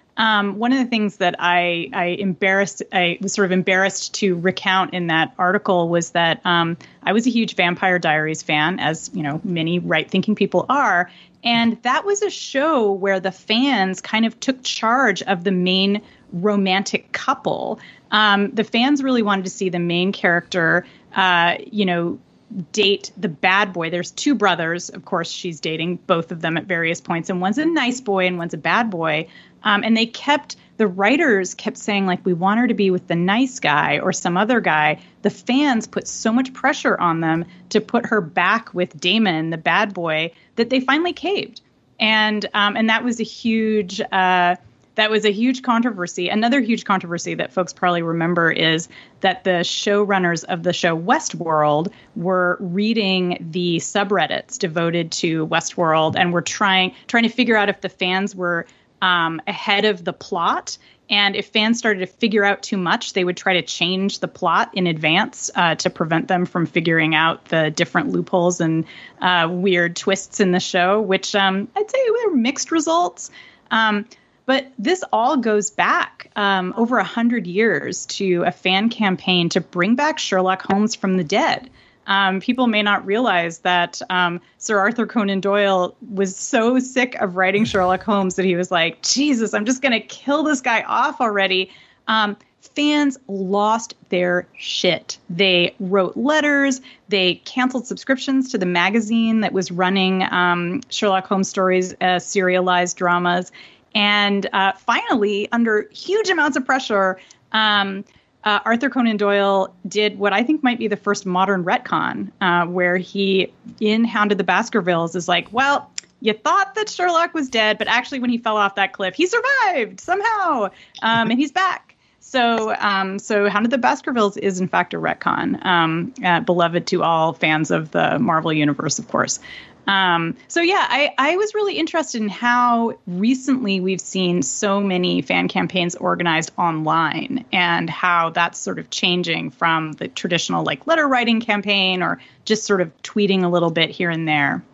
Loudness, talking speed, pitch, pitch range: -19 LUFS, 180 wpm, 195 Hz, 180-225 Hz